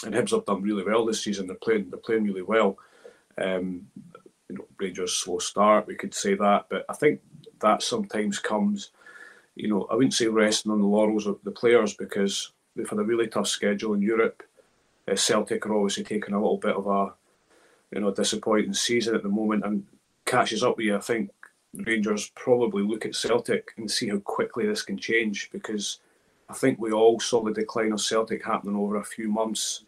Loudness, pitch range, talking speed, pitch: -26 LUFS, 100-110 Hz, 205 wpm, 105 Hz